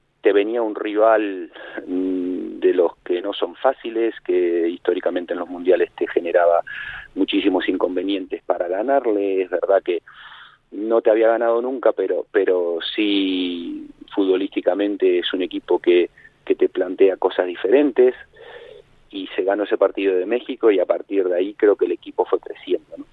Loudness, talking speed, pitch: -20 LUFS, 160 wpm, 365 Hz